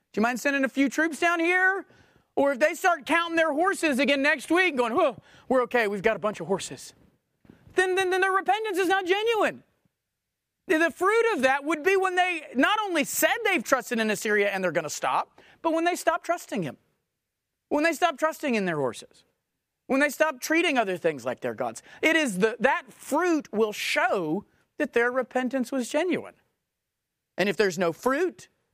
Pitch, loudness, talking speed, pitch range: 300 Hz, -25 LUFS, 200 wpm, 240-345 Hz